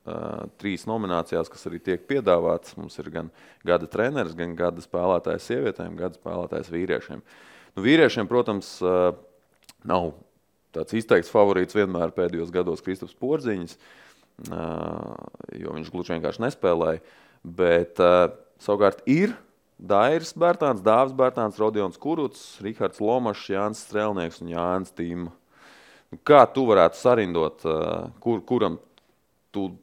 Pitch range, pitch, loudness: 85-110 Hz, 90 Hz, -24 LUFS